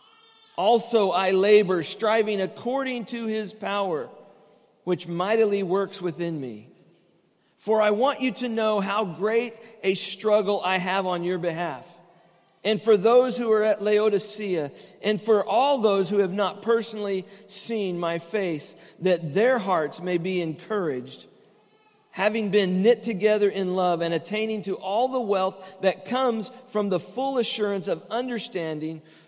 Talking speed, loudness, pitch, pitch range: 150 wpm, -24 LUFS, 205 Hz, 180-220 Hz